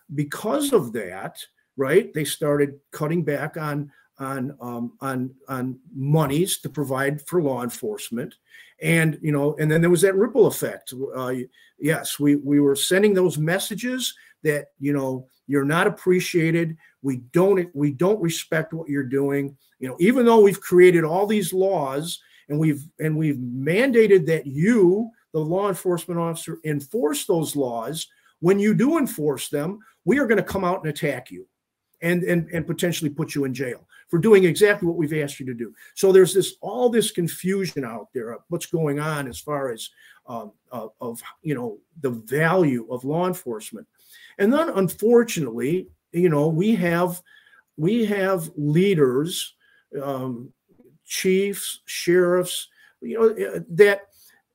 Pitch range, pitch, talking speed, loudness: 145-190 Hz, 165 Hz, 160 wpm, -22 LUFS